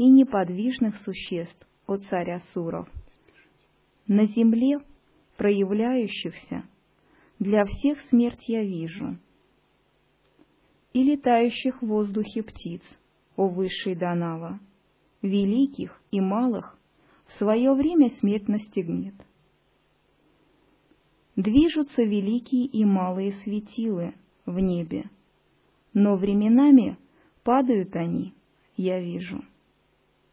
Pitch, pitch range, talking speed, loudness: 210 Hz, 190-240 Hz, 85 wpm, -24 LUFS